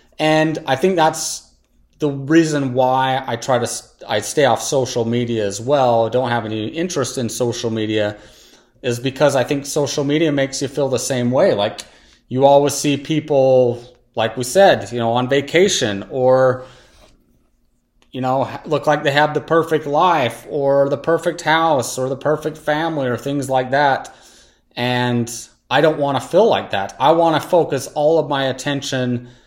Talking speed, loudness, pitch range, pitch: 175 wpm, -17 LUFS, 120-150 Hz, 135 Hz